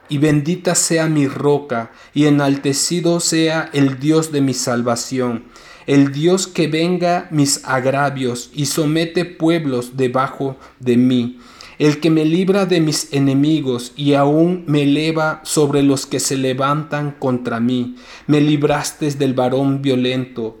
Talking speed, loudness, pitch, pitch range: 140 wpm, -17 LUFS, 145 Hz, 130-155 Hz